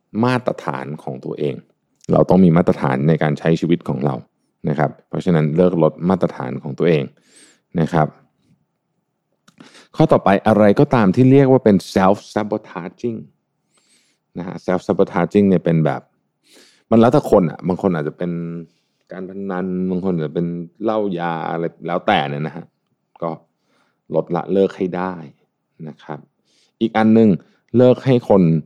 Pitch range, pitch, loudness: 80-105 Hz, 90 Hz, -17 LUFS